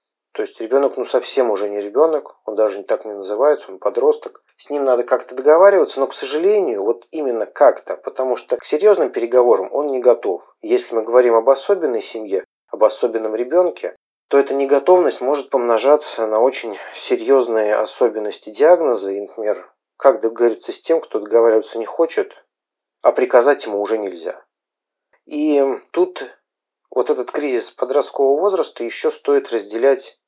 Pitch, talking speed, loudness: 165 Hz, 155 wpm, -17 LUFS